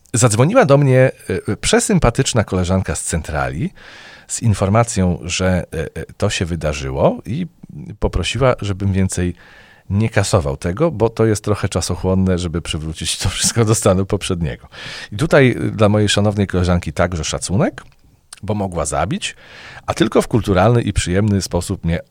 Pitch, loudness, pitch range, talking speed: 100 Hz, -17 LUFS, 90-110 Hz, 140 wpm